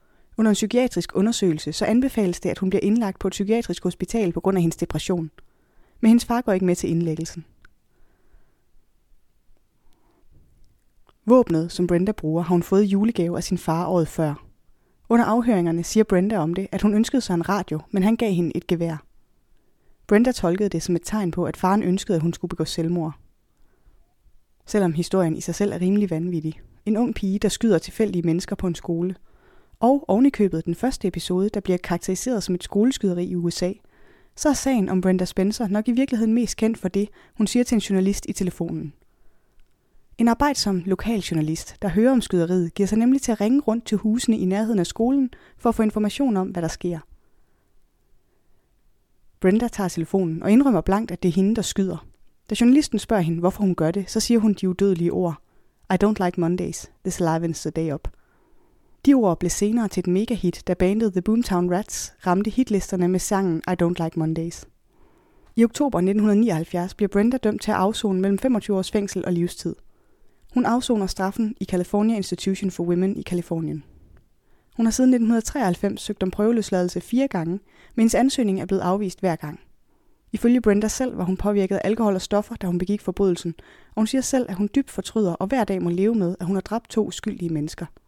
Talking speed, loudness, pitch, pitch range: 195 wpm, -22 LUFS, 195 Hz, 175-220 Hz